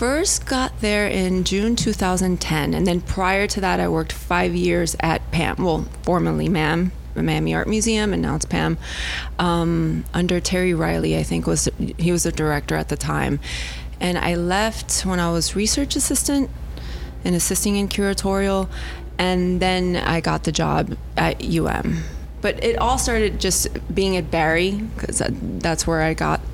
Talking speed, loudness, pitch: 170 wpm, -21 LUFS, 175 Hz